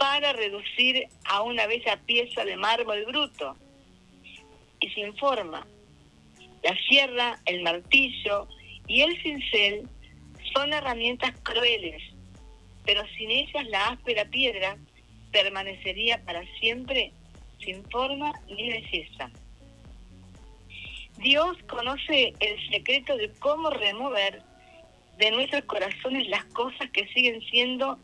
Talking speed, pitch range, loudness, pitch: 105 wpm, 170-260 Hz, -25 LUFS, 220 Hz